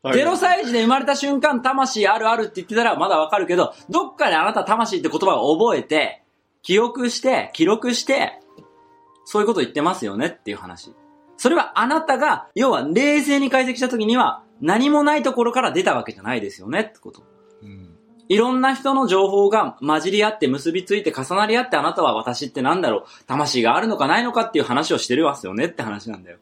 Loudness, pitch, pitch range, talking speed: -19 LUFS, 235 Hz, 195-275 Hz, 425 characters per minute